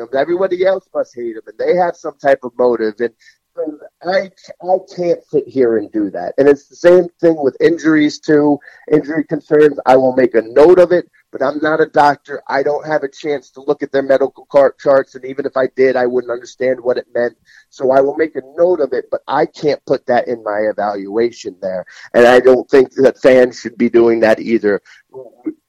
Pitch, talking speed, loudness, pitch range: 145 Hz, 220 wpm, -14 LUFS, 125-175 Hz